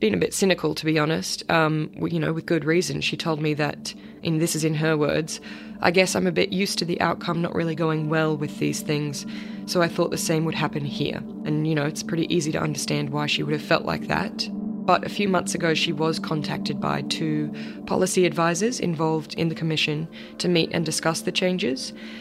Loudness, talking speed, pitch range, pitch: -24 LUFS, 225 wpm, 155-180 Hz, 165 Hz